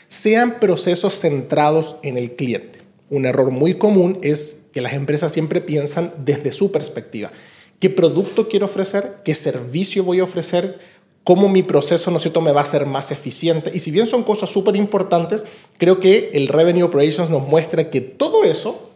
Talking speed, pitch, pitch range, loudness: 175 wpm, 170 Hz, 150-195 Hz, -17 LUFS